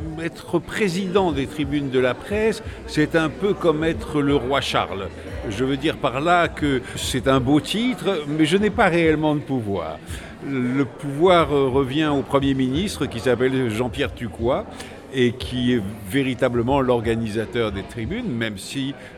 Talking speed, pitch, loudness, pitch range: 160 wpm, 140 Hz, -22 LUFS, 125-155 Hz